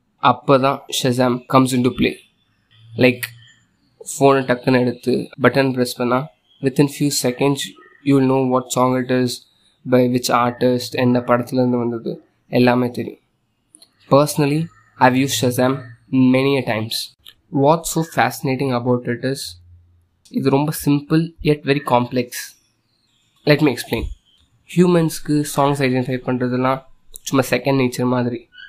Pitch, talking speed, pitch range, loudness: 125 Hz, 130 wpm, 120-140 Hz, -18 LUFS